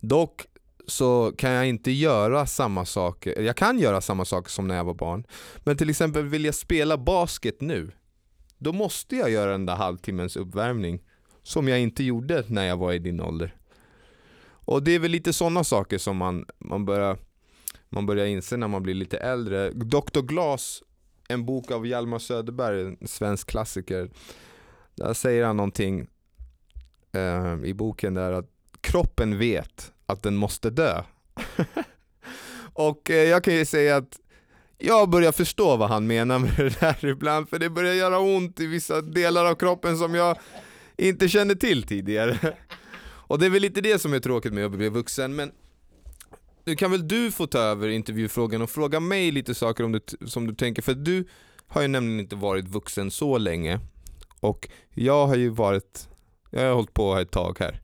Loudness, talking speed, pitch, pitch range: -25 LUFS, 180 wpm, 115 Hz, 95-155 Hz